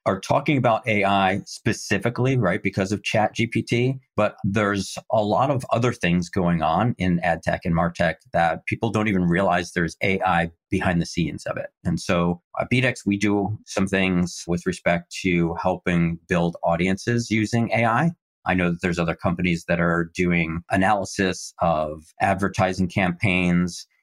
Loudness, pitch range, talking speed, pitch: -23 LUFS, 85-105 Hz, 160 wpm, 95 Hz